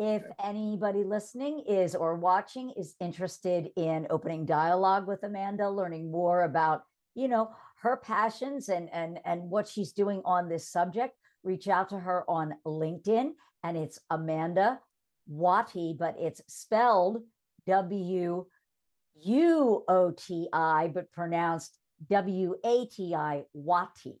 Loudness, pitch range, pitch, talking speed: -30 LUFS, 165-205 Hz, 185 Hz, 135 wpm